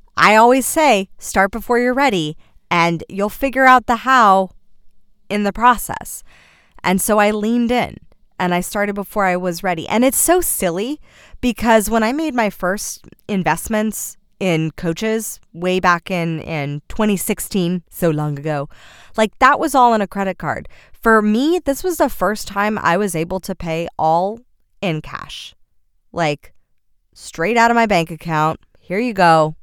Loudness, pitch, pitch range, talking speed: -17 LUFS, 200 Hz, 170-230 Hz, 165 wpm